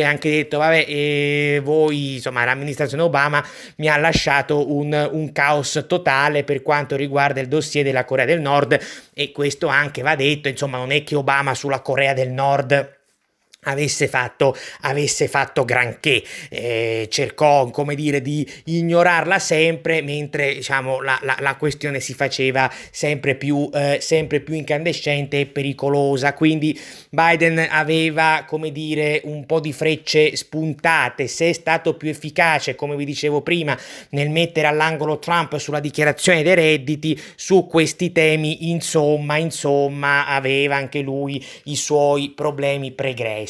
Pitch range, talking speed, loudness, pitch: 140-155 Hz, 145 wpm, -19 LUFS, 145 Hz